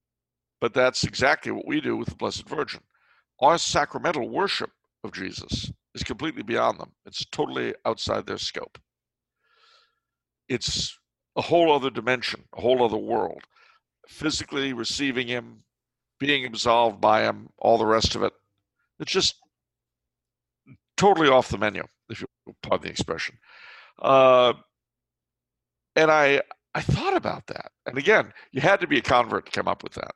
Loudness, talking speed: -24 LUFS, 155 wpm